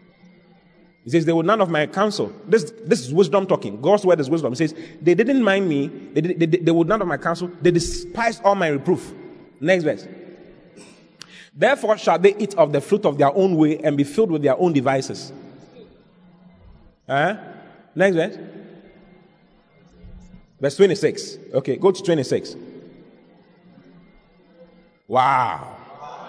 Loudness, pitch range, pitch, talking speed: -20 LUFS, 165-195 Hz, 175 Hz, 155 wpm